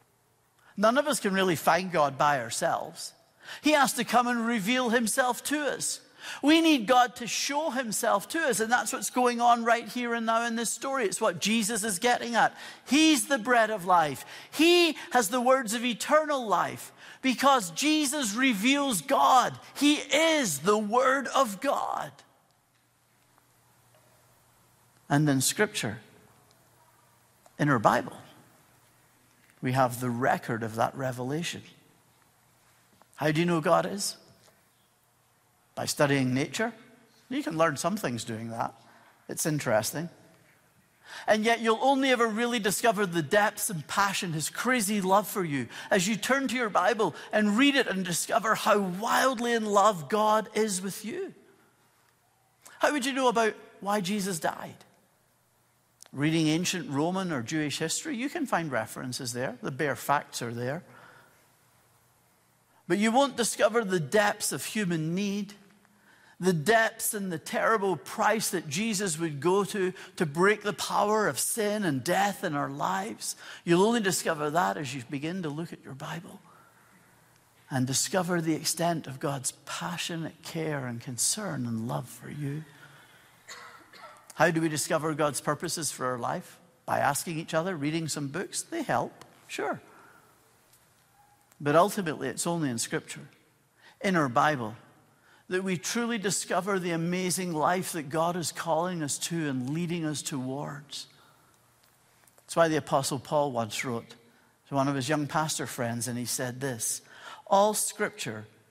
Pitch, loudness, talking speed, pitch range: 185 Hz, -27 LUFS, 155 wpm, 150-230 Hz